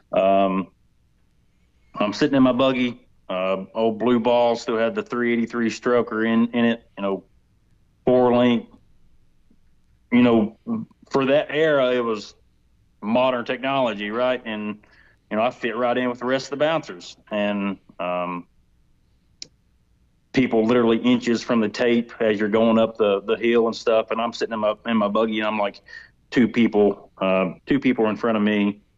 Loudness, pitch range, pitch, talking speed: -21 LUFS, 105-125 Hz, 115 Hz, 170 wpm